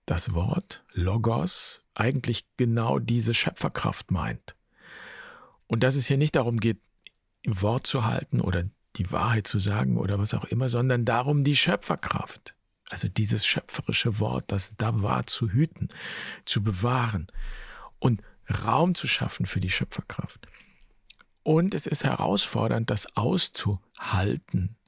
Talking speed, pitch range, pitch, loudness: 135 wpm, 105-130 Hz, 115 Hz, -26 LUFS